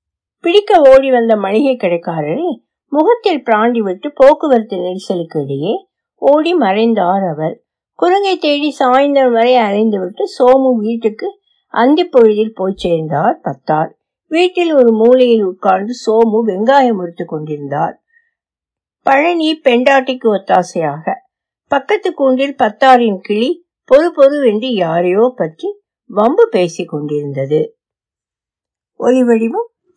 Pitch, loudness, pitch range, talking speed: 245 Hz, -13 LUFS, 195-310 Hz, 85 wpm